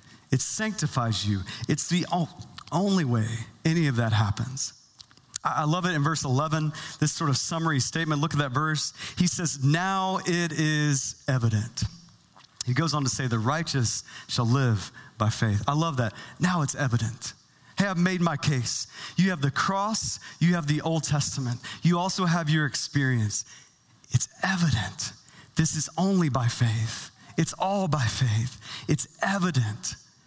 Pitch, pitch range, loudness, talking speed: 145 Hz, 120-165 Hz, -26 LUFS, 160 wpm